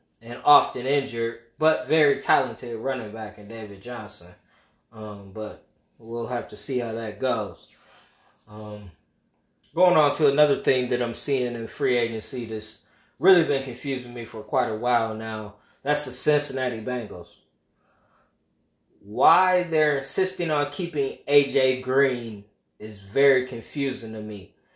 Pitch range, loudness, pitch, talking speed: 110-140 Hz, -24 LUFS, 120 Hz, 140 wpm